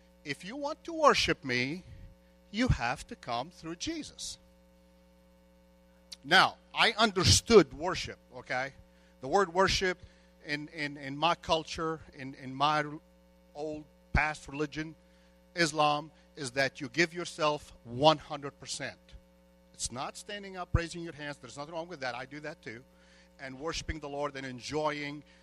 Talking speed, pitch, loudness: 140 wpm, 145 Hz, -31 LUFS